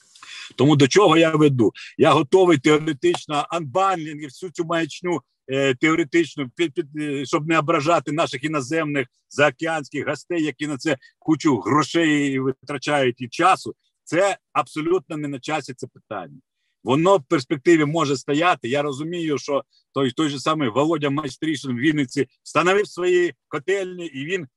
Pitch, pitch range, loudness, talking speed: 155 Hz, 140-170 Hz, -21 LUFS, 140 wpm